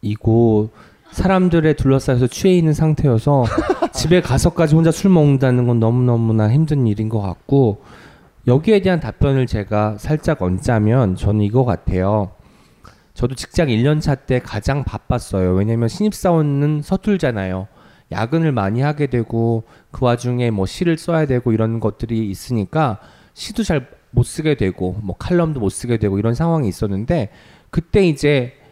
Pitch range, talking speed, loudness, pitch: 110-155 Hz, 320 characters per minute, -17 LUFS, 125 Hz